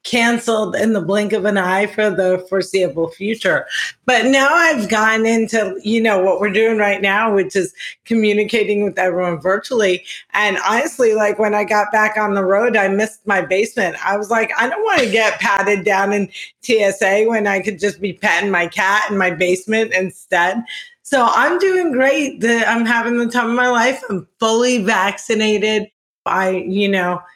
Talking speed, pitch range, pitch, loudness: 185 wpm, 195-225 Hz, 210 Hz, -16 LUFS